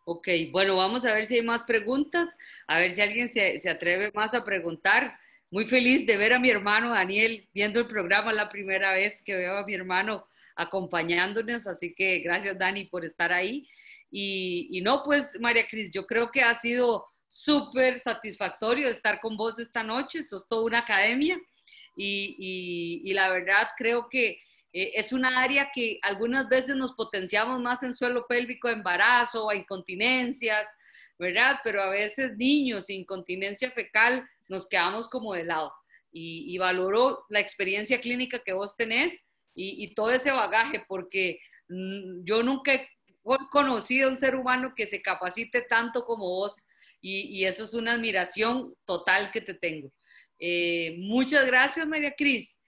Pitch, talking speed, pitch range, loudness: 215 Hz, 165 wpm, 190-245 Hz, -26 LUFS